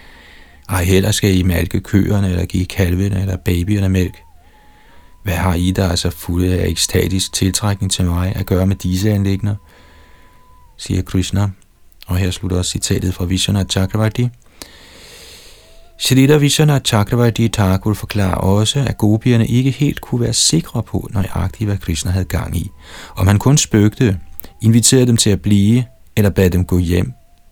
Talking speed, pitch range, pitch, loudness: 160 wpm, 90-105 Hz, 95 Hz, -16 LUFS